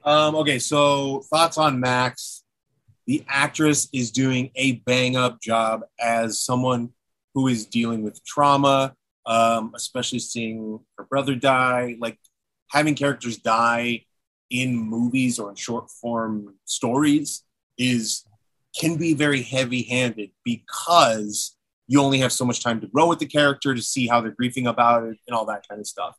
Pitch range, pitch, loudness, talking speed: 115-140 Hz, 125 Hz, -22 LUFS, 160 wpm